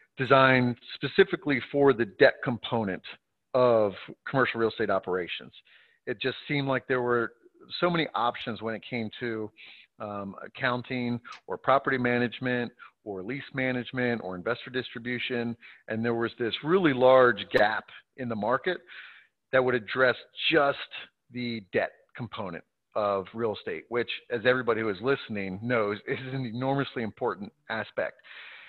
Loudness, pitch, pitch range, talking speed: -28 LUFS, 125 Hz, 115-130 Hz, 140 wpm